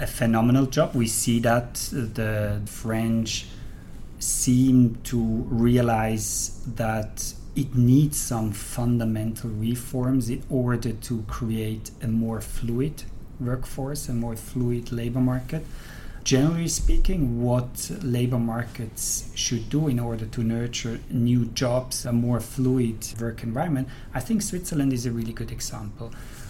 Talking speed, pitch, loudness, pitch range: 125 wpm, 120 Hz, -25 LUFS, 115-130 Hz